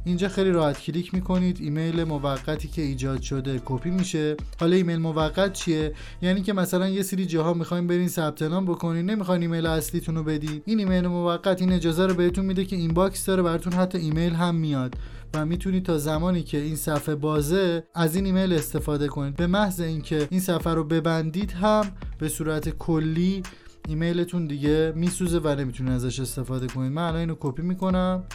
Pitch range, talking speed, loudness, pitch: 155-180 Hz, 180 wpm, -25 LUFS, 165 Hz